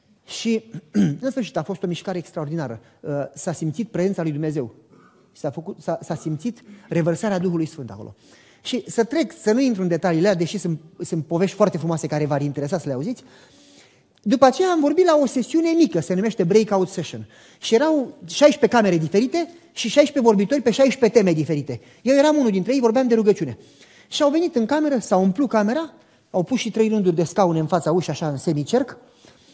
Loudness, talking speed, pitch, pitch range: -21 LUFS, 195 wpm, 195 Hz, 165-245 Hz